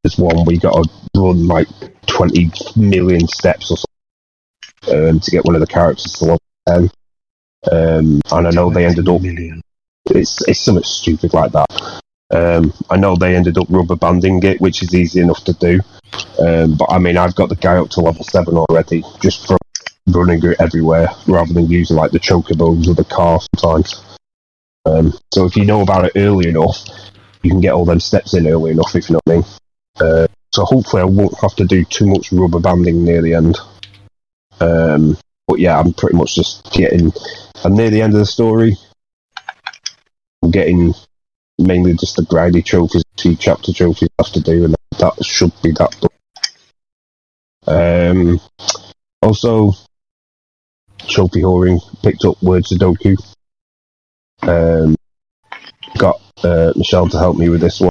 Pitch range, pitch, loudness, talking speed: 85-95 Hz, 85 Hz, -13 LUFS, 180 wpm